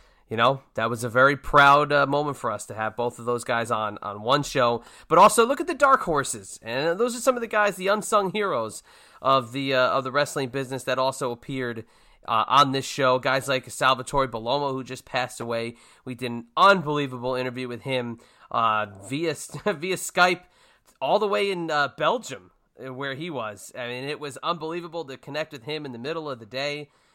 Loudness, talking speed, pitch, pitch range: -24 LUFS, 210 wpm, 135 Hz, 125-160 Hz